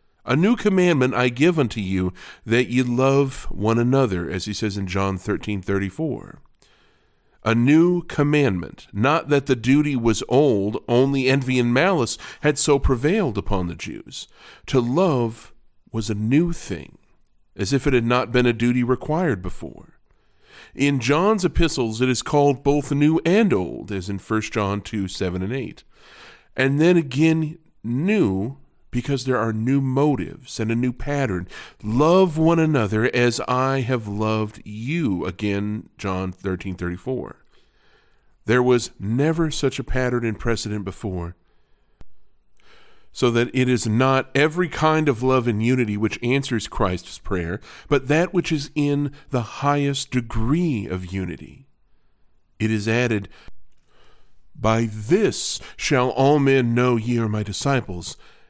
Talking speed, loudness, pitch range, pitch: 150 wpm, -21 LUFS, 105-140 Hz, 125 Hz